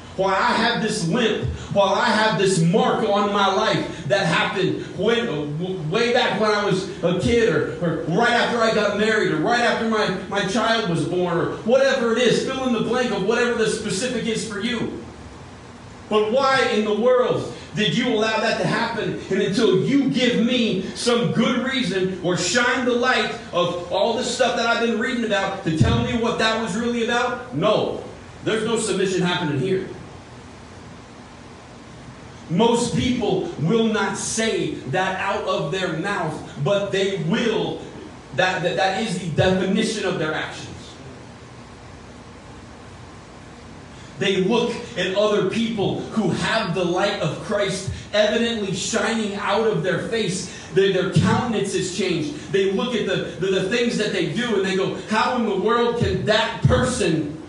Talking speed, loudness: 170 wpm, -21 LUFS